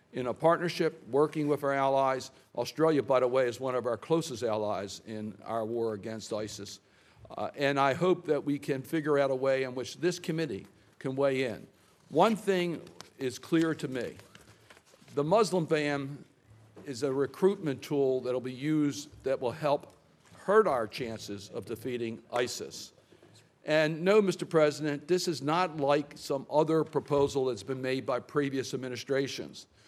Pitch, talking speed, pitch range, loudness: 140 Hz, 165 wpm, 125-155 Hz, -30 LUFS